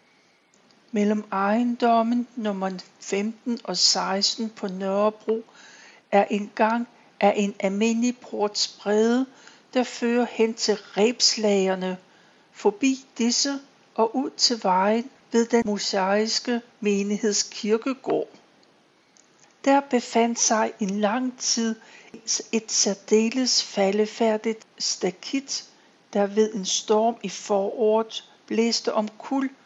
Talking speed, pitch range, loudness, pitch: 100 wpm, 205-235 Hz, -24 LUFS, 220 Hz